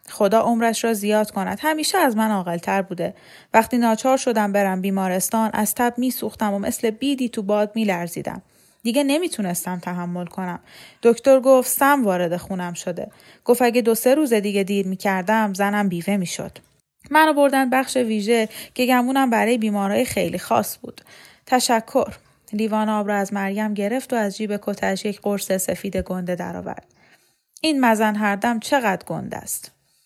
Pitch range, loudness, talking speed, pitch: 200-245 Hz, -21 LUFS, 155 wpm, 215 Hz